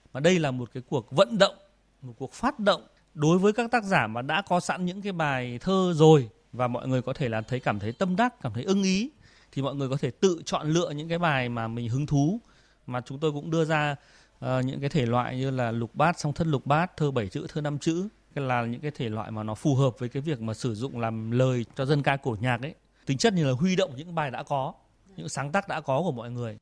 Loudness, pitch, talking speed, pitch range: -27 LUFS, 145 Hz, 275 wpm, 125-170 Hz